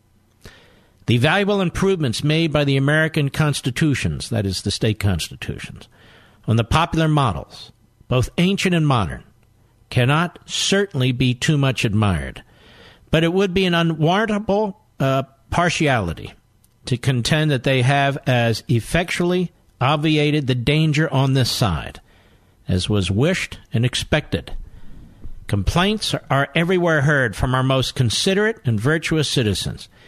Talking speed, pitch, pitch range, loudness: 130 wpm, 130 Hz, 110-155 Hz, -19 LUFS